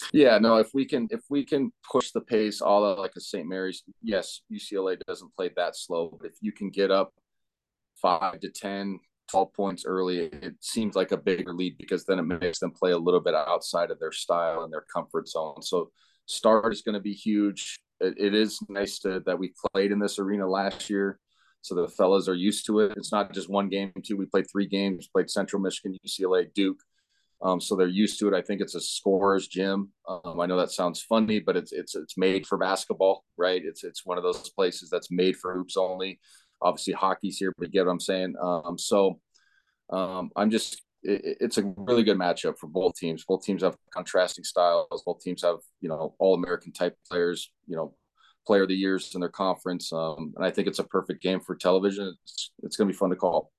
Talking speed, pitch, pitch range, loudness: 225 wpm, 95 Hz, 95-105 Hz, -27 LUFS